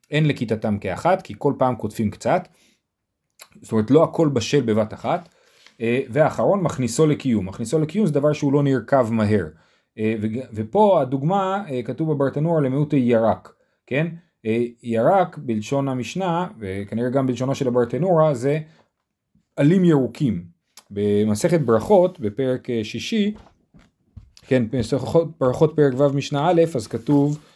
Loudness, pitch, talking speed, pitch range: -21 LUFS, 135 Hz, 125 wpm, 115-155 Hz